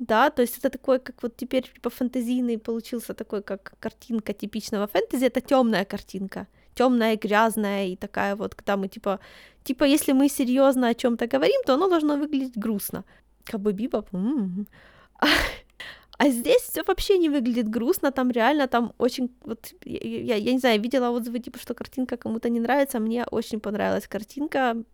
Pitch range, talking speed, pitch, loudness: 220-265 Hz, 170 wpm, 240 Hz, -25 LUFS